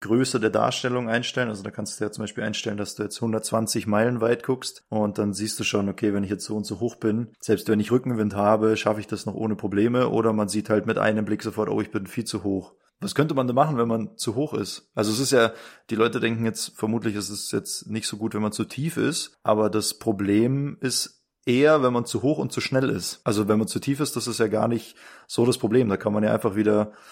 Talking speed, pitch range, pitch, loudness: 270 wpm, 105-120 Hz, 110 Hz, -24 LUFS